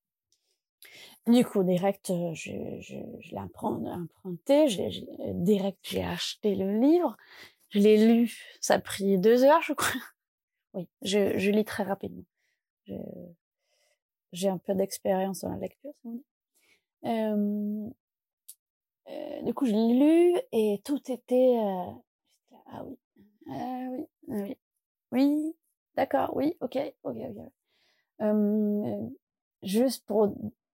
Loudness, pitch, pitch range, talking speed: -27 LUFS, 230 Hz, 200-285 Hz, 125 wpm